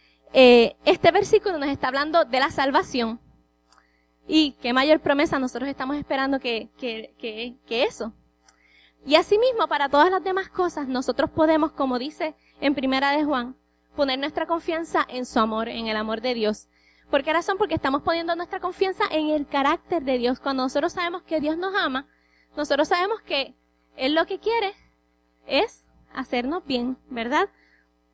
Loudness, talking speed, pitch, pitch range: -23 LUFS, 165 wpm, 280 Hz, 245-330 Hz